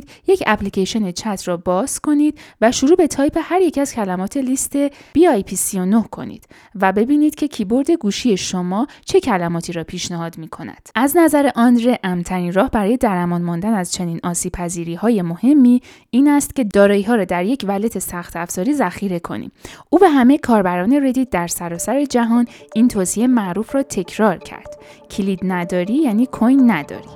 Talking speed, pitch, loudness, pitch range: 180 wpm, 215 Hz, -17 LUFS, 180-270 Hz